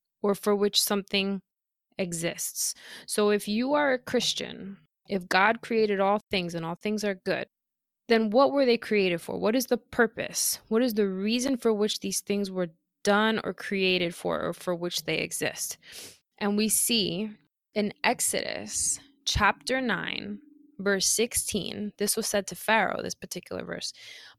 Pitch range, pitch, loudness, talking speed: 195-225 Hz, 205 Hz, -27 LUFS, 160 wpm